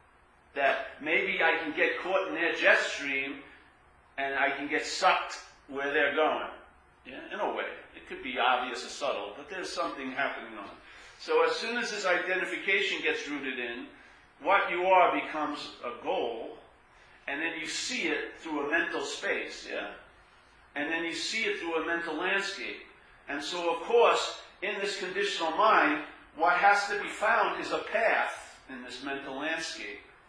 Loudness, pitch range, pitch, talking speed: -29 LUFS, 140-200 Hz, 165 Hz, 175 wpm